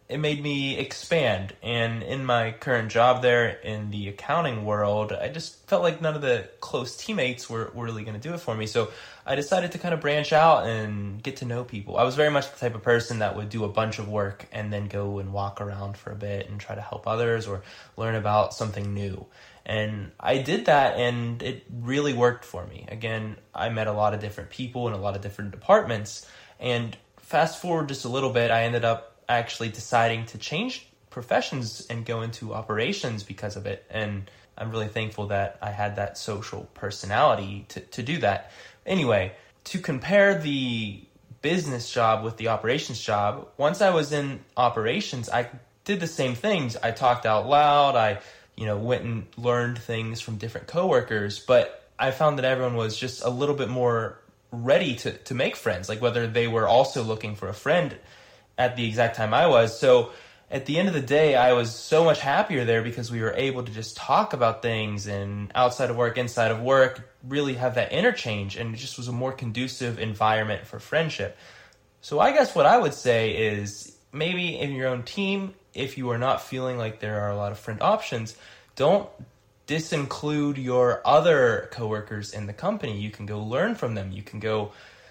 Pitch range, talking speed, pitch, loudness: 105-130 Hz, 205 wpm, 115 Hz, -25 LUFS